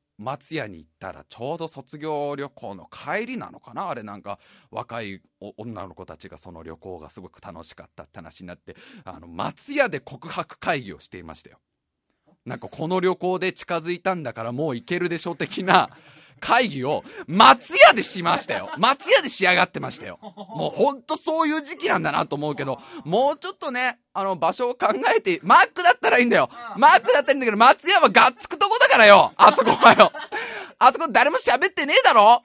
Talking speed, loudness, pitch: 390 characters per minute, -19 LUFS, 185 Hz